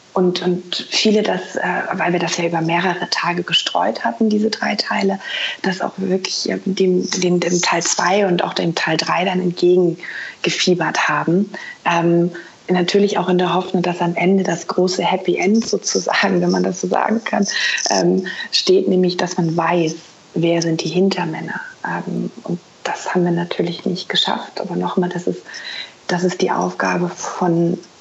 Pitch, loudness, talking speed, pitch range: 180 Hz, -18 LUFS, 175 wpm, 175-190 Hz